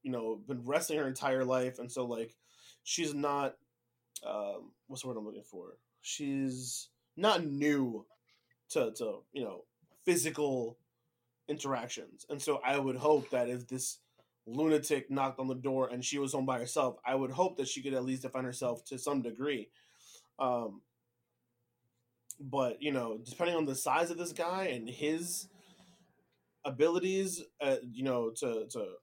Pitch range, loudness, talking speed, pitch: 125-155 Hz, -35 LUFS, 165 wpm, 135 Hz